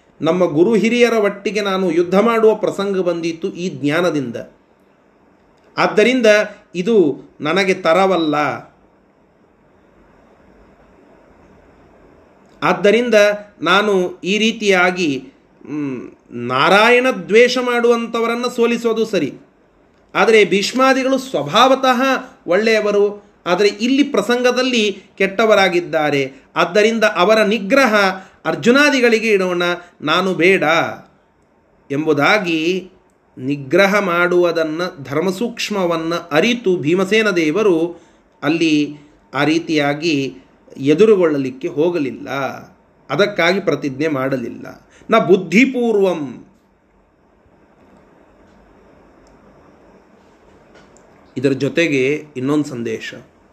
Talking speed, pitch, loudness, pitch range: 65 wpm, 190 Hz, -16 LUFS, 160-220 Hz